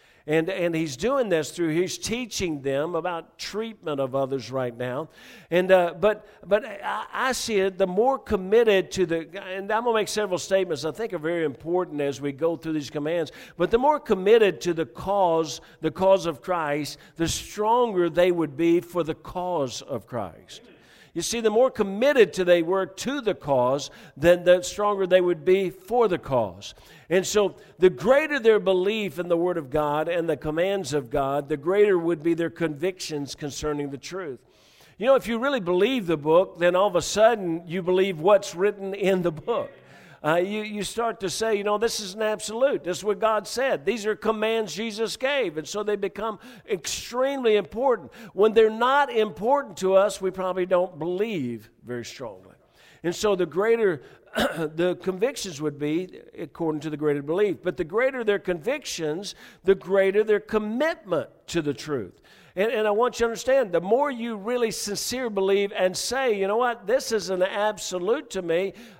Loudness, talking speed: -24 LUFS, 190 wpm